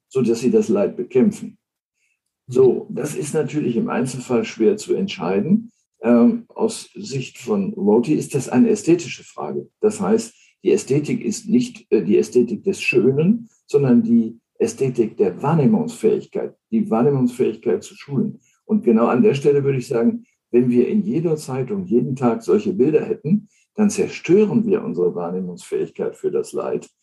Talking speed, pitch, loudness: 155 wpm, 205 Hz, -19 LUFS